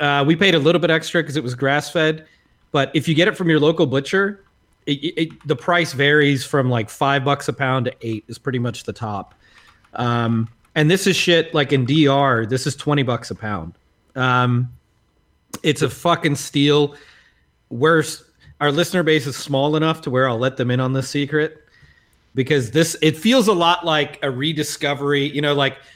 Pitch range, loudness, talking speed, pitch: 130-160 Hz, -19 LUFS, 200 wpm, 145 Hz